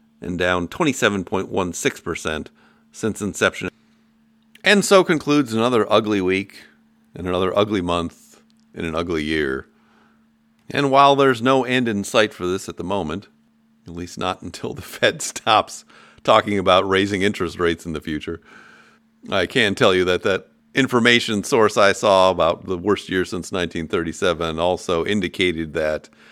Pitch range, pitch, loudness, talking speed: 90-145 Hz, 100 Hz, -19 LUFS, 150 wpm